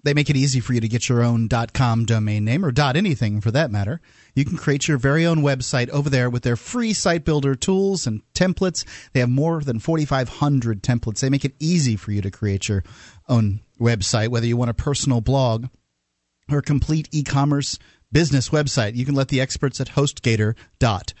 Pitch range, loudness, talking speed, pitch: 115-145 Hz, -21 LUFS, 200 wpm, 130 Hz